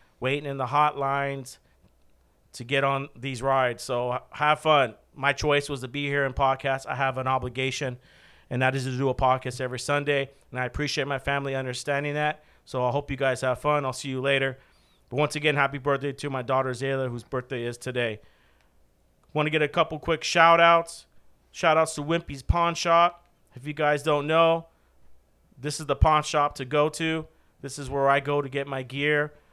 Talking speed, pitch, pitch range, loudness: 205 wpm, 140 Hz, 130-150 Hz, -25 LUFS